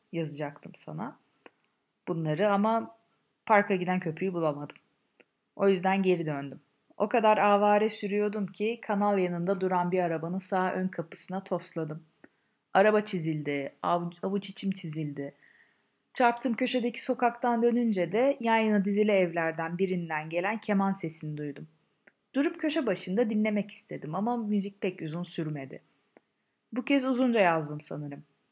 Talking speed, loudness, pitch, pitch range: 125 wpm, -29 LUFS, 195 Hz, 165-215 Hz